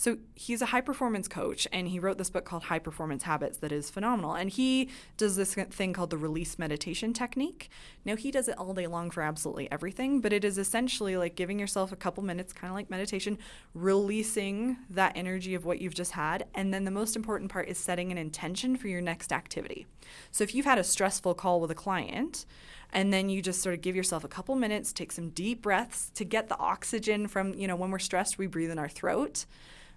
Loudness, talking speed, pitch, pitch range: -32 LUFS, 230 wpm, 190 Hz, 175-210 Hz